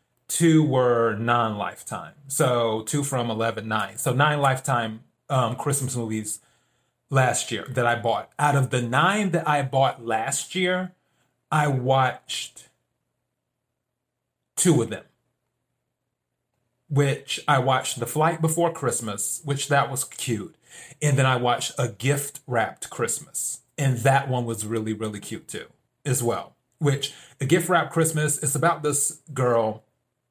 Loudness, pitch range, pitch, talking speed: -24 LUFS, 120-145 Hz, 130 Hz, 145 wpm